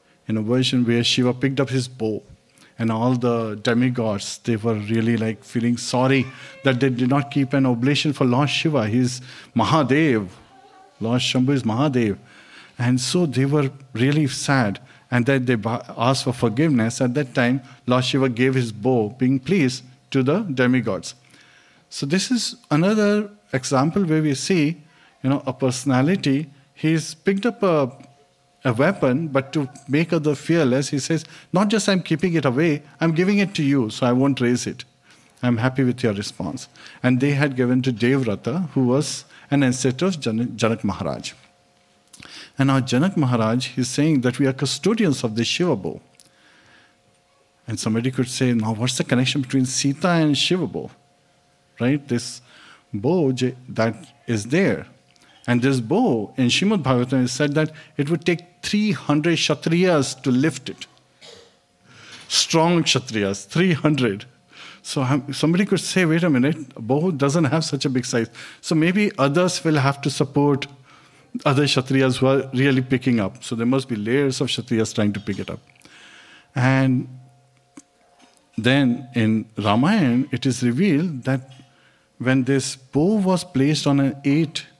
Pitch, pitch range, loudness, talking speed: 135 Hz, 125-150 Hz, -21 LUFS, 165 wpm